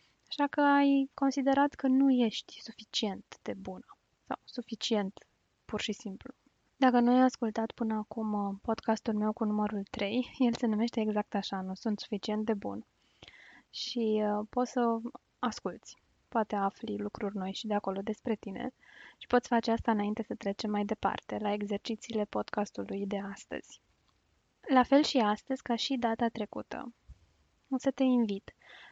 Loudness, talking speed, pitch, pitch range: -32 LUFS, 155 wpm, 225 Hz, 210-250 Hz